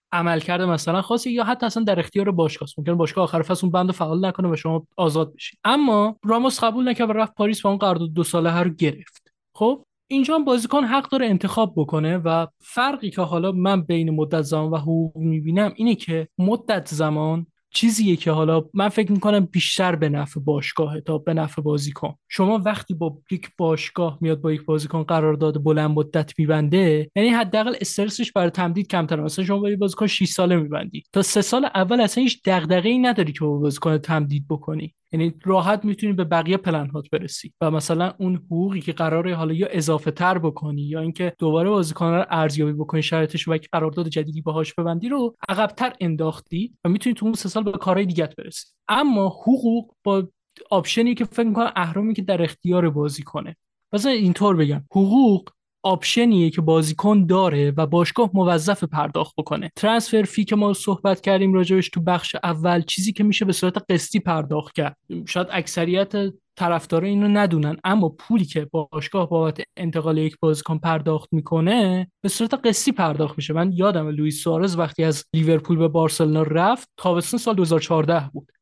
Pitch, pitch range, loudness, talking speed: 175 Hz, 160-205 Hz, -21 LUFS, 180 wpm